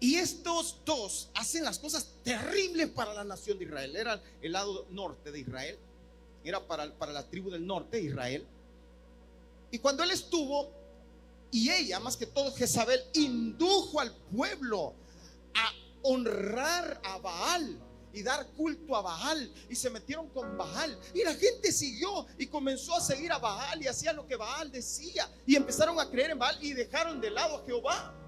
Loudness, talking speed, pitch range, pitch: -33 LUFS, 175 wpm, 195-320 Hz, 265 Hz